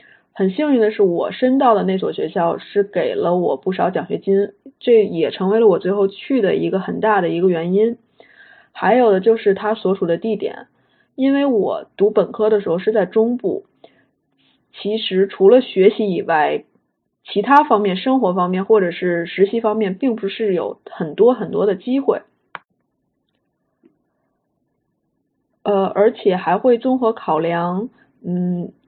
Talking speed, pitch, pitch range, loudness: 225 characters per minute, 210 Hz, 190-235 Hz, -17 LUFS